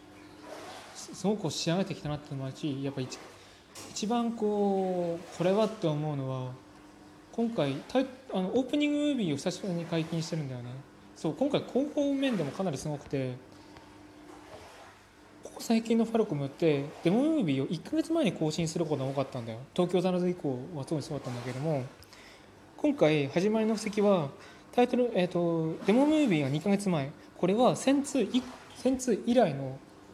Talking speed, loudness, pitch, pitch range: 350 characters per minute, -30 LUFS, 170 Hz, 140-220 Hz